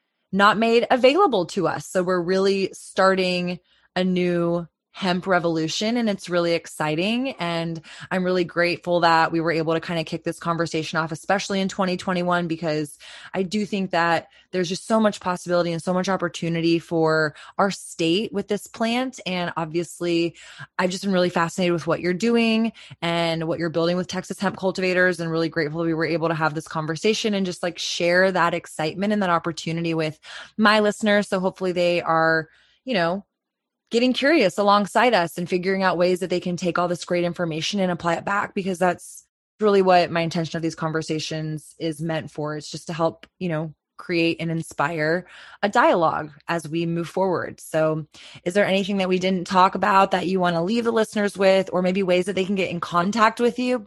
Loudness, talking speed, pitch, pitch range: -22 LUFS, 200 wpm, 175 Hz, 165-195 Hz